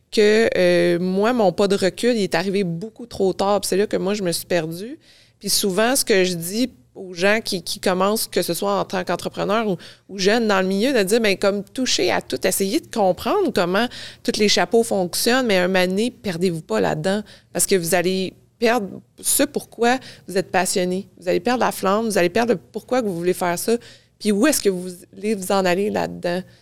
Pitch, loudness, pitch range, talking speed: 200 Hz, -20 LUFS, 185-225 Hz, 225 wpm